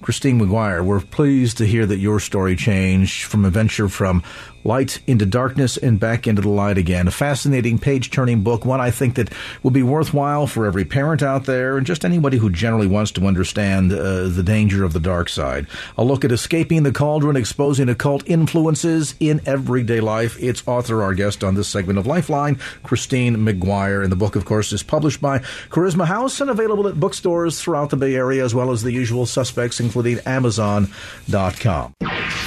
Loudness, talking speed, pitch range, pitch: -19 LUFS, 190 wpm, 105-140 Hz, 120 Hz